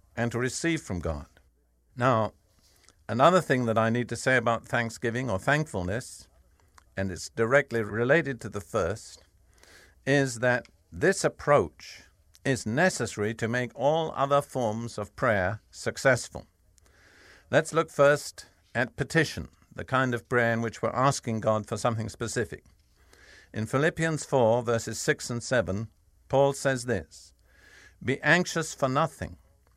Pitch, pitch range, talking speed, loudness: 115 Hz, 95-135 Hz, 140 wpm, -27 LUFS